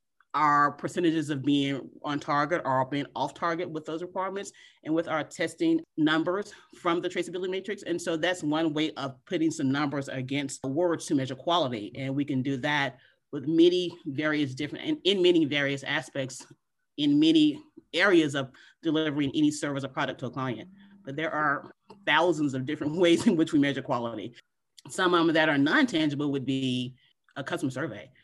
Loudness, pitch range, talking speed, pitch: -27 LUFS, 140-175 Hz, 185 wpm, 155 Hz